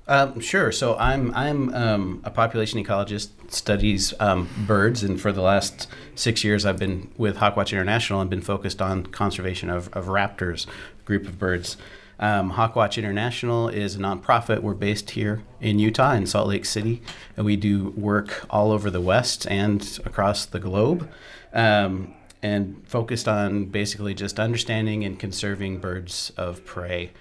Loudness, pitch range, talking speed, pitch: -24 LUFS, 95-110 Hz, 165 wpm, 105 Hz